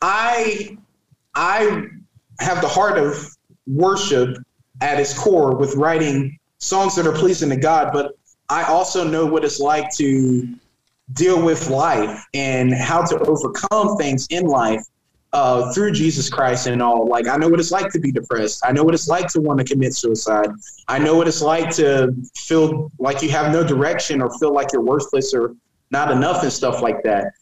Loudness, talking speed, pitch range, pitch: -18 LUFS, 185 wpm, 130-170 Hz, 150 Hz